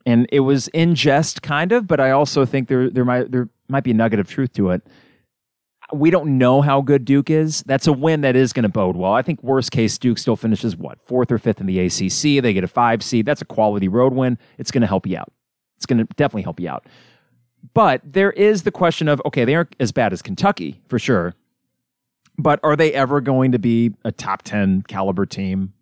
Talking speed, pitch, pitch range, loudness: 240 wpm, 130 Hz, 115-150 Hz, -18 LUFS